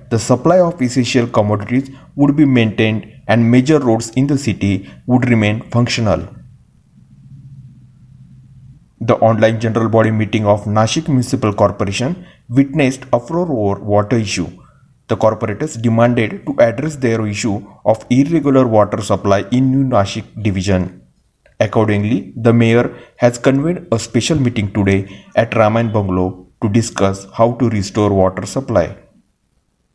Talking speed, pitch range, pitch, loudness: 130 wpm, 105-130 Hz, 115 Hz, -15 LUFS